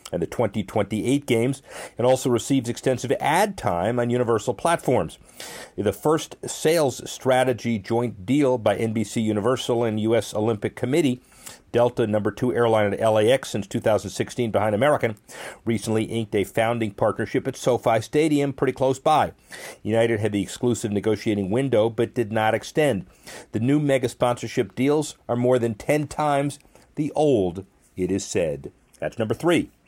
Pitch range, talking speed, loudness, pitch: 110-130 Hz, 150 wpm, -23 LUFS, 120 Hz